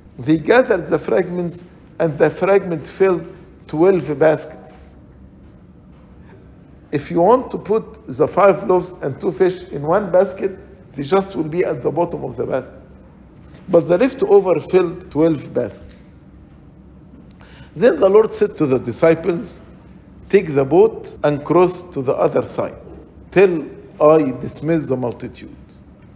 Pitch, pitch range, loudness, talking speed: 175 Hz, 155-195 Hz, -17 LUFS, 140 wpm